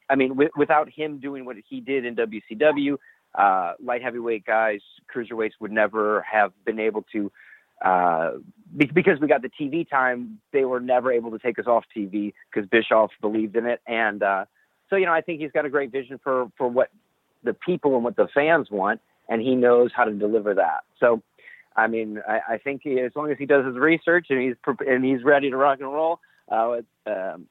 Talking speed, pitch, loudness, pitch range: 220 wpm, 130 Hz, -23 LUFS, 115-145 Hz